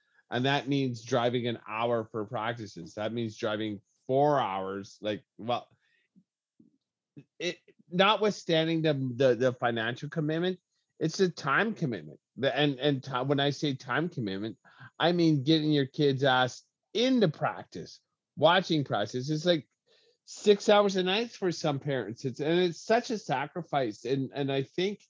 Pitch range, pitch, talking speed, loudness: 125-175 Hz, 145 Hz, 150 wpm, -29 LUFS